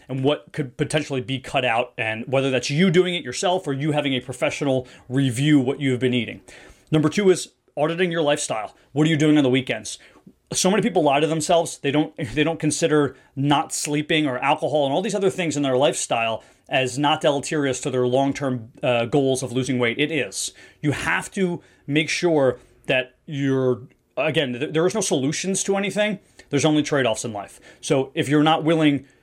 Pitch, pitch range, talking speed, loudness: 145 Hz, 130-155 Hz, 200 wpm, -22 LUFS